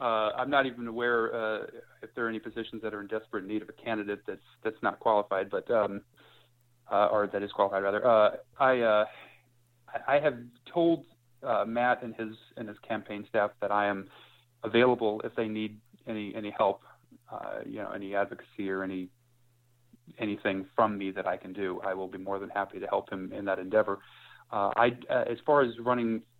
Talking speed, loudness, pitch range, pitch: 200 wpm, -30 LUFS, 100-120 Hz, 110 Hz